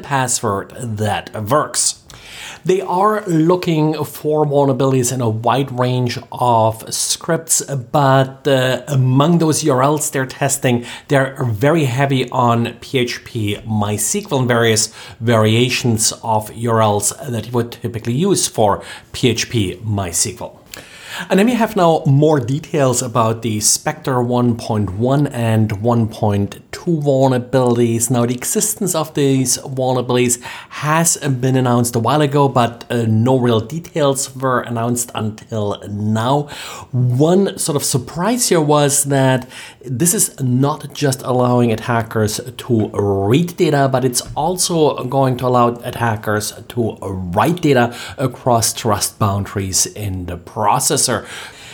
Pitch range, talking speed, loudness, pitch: 115-140 Hz, 125 wpm, -16 LUFS, 125 Hz